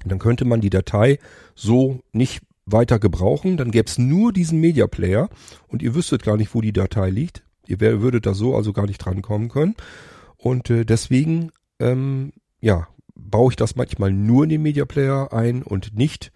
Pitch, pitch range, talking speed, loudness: 120 Hz, 105-135 Hz, 185 wpm, -20 LUFS